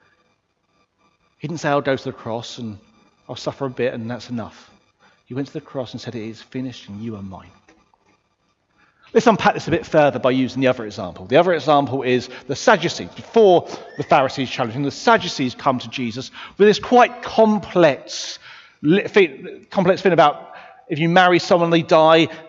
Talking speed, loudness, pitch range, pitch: 185 wpm, -18 LUFS, 125-165 Hz, 135 Hz